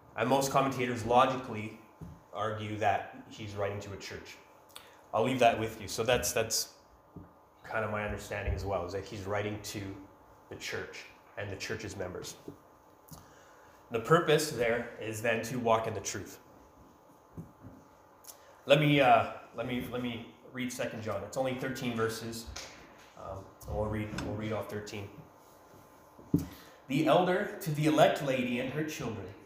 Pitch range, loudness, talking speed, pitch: 105-130 Hz, -32 LUFS, 155 wpm, 115 Hz